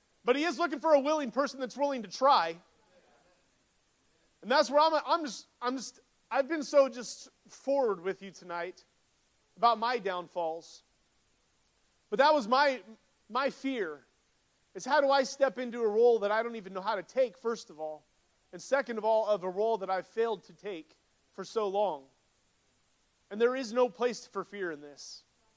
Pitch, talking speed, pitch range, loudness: 230 Hz, 190 wpm, 190-275 Hz, -30 LUFS